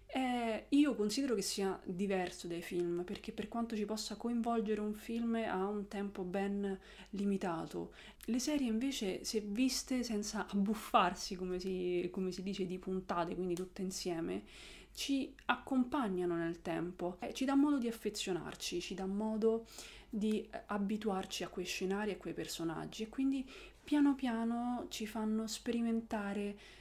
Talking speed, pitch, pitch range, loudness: 150 wpm, 205 Hz, 185-230 Hz, -38 LUFS